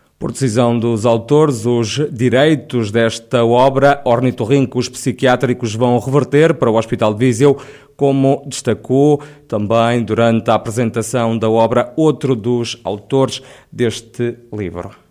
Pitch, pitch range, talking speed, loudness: 120 Hz, 115-135 Hz, 125 wpm, -15 LUFS